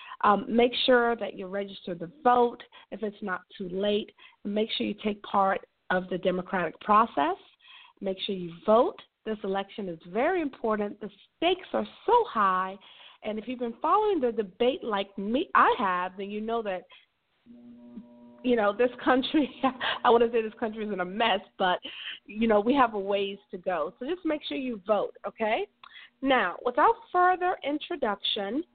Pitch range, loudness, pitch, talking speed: 200-265 Hz, -27 LUFS, 225 Hz, 175 wpm